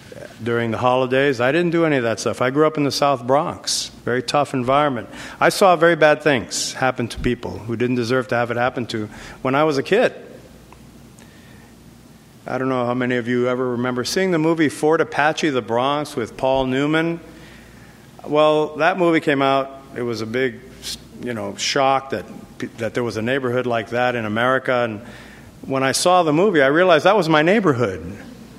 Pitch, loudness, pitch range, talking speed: 130 Hz, -19 LUFS, 120-145 Hz, 195 wpm